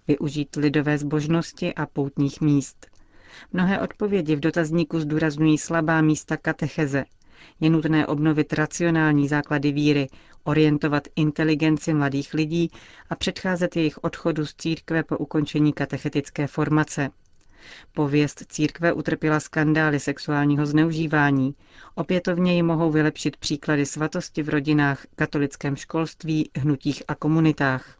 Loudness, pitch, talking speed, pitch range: -23 LUFS, 155 Hz, 115 wpm, 145-160 Hz